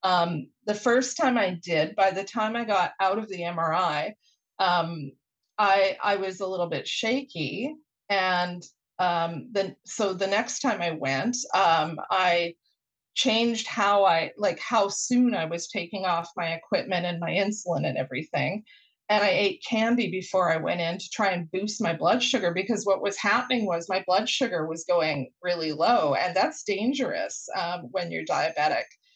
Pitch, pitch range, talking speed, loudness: 195 Hz, 175-225 Hz, 175 wpm, -26 LUFS